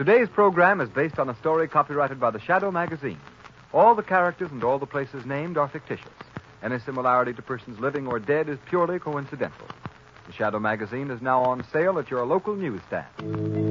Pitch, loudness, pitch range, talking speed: 140 Hz, -25 LUFS, 125-165 Hz, 190 wpm